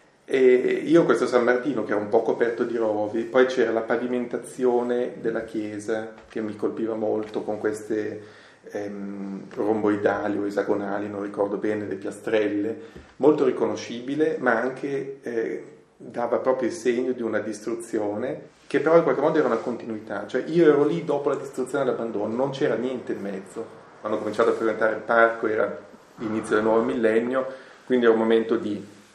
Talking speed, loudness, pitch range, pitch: 170 wpm, -24 LUFS, 105-125 Hz, 115 Hz